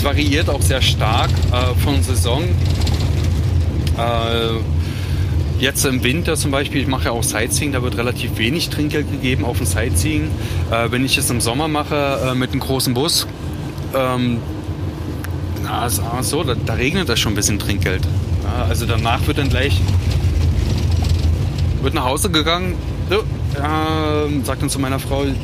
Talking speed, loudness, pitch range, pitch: 160 wpm, -18 LUFS, 90-115 Hz, 100 Hz